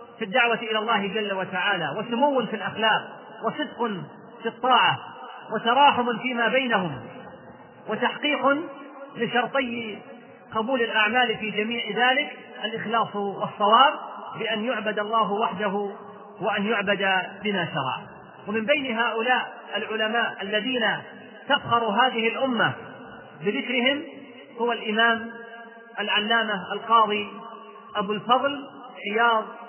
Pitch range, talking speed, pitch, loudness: 210-245 Hz, 95 wpm, 225 Hz, -24 LUFS